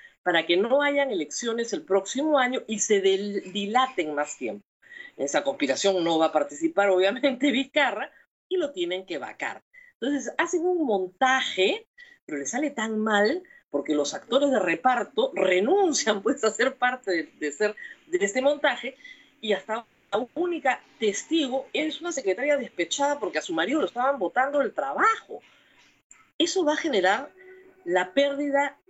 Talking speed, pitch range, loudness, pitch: 160 wpm, 200-295 Hz, -25 LUFS, 260 Hz